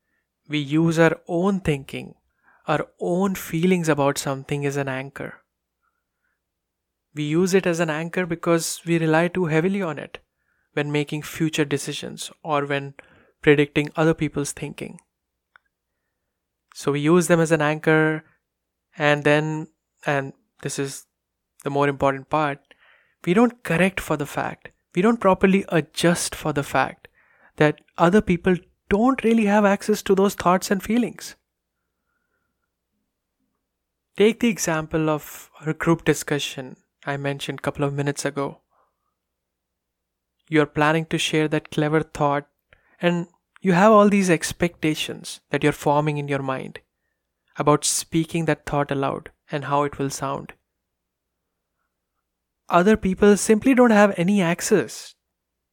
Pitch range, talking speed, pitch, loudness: 145-175 Hz, 135 wpm, 155 Hz, -22 LUFS